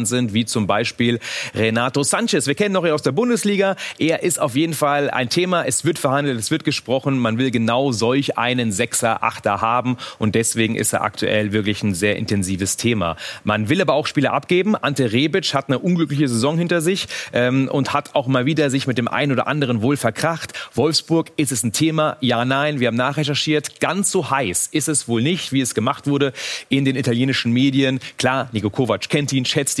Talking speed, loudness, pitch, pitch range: 210 wpm, -19 LUFS, 135 Hz, 120-155 Hz